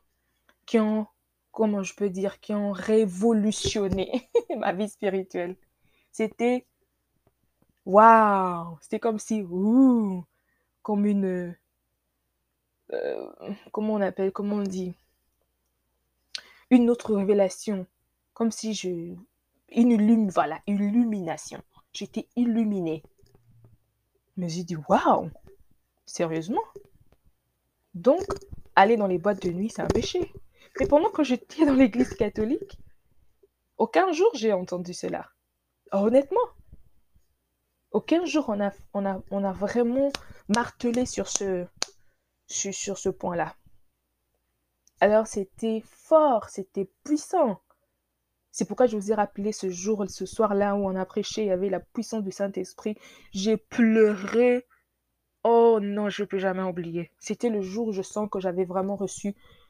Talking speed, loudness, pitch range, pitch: 130 wpm, -25 LUFS, 185-230 Hz, 205 Hz